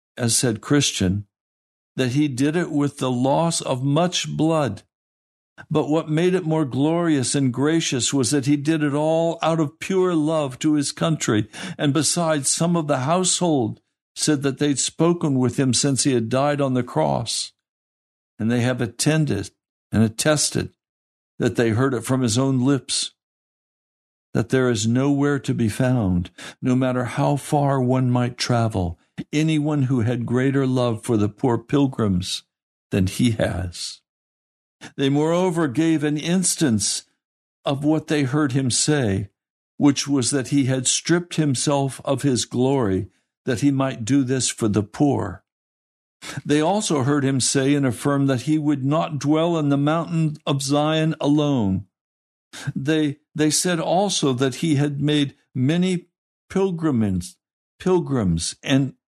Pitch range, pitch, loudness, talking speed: 120-155 Hz, 140 Hz, -21 LUFS, 155 wpm